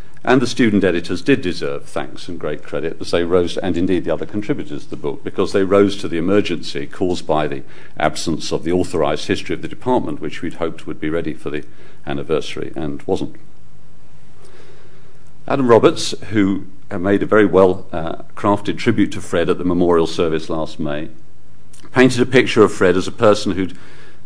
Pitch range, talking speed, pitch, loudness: 85-105 Hz, 190 wpm, 95 Hz, -18 LUFS